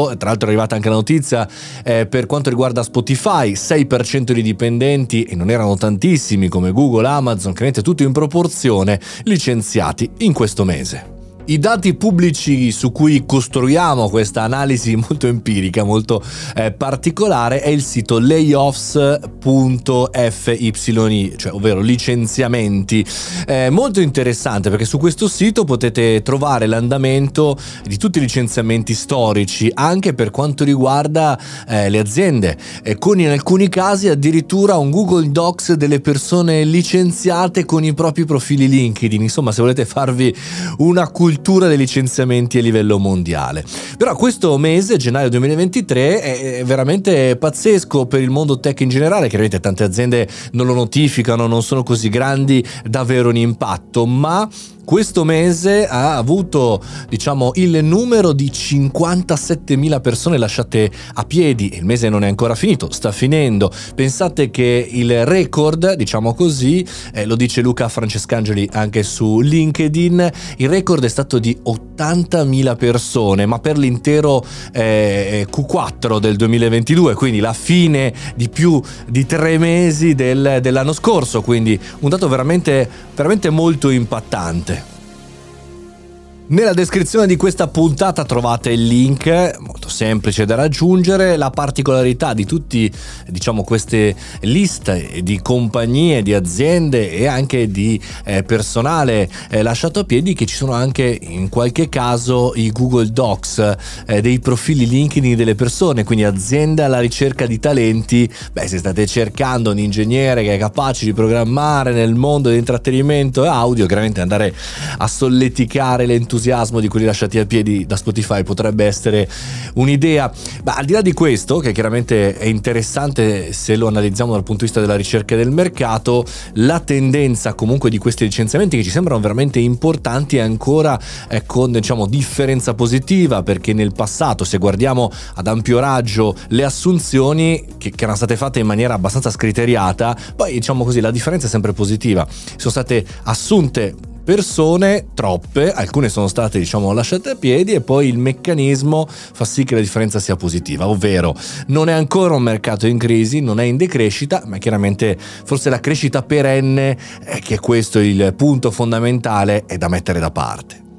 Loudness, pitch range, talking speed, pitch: -15 LUFS, 110-150 Hz, 150 wpm, 125 Hz